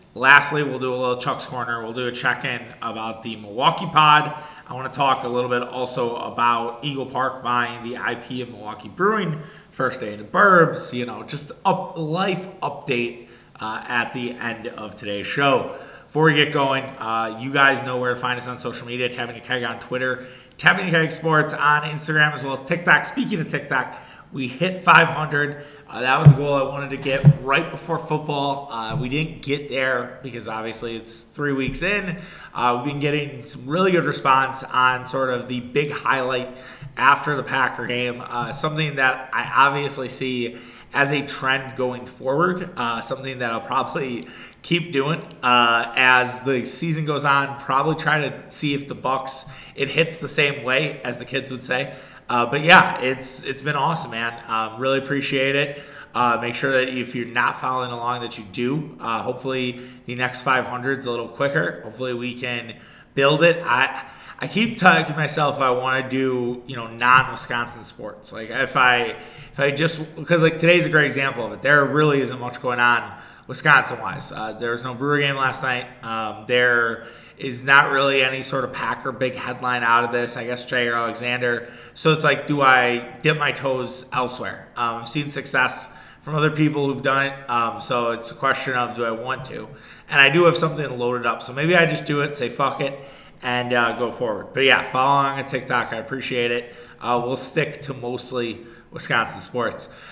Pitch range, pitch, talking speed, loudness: 120-145 Hz, 130 Hz, 200 wpm, -21 LUFS